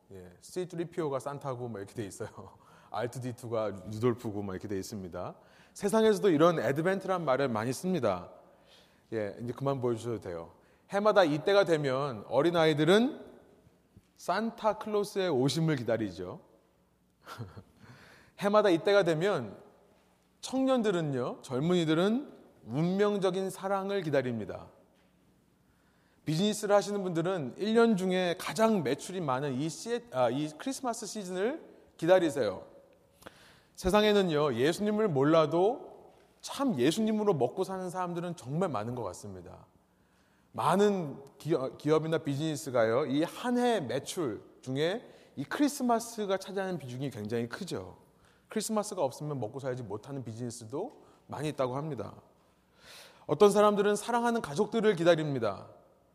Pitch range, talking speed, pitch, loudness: 125-205 Hz, 300 characters per minute, 165 Hz, -30 LUFS